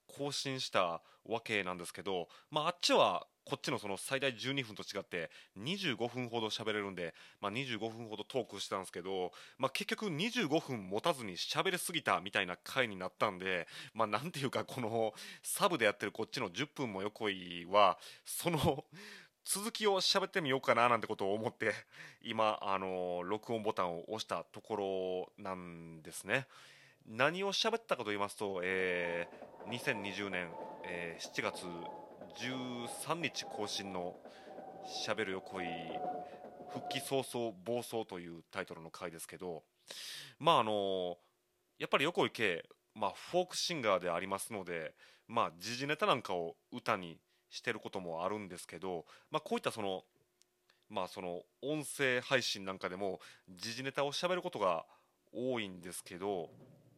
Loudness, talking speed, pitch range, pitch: -37 LUFS, 305 characters per minute, 95-135 Hz, 110 Hz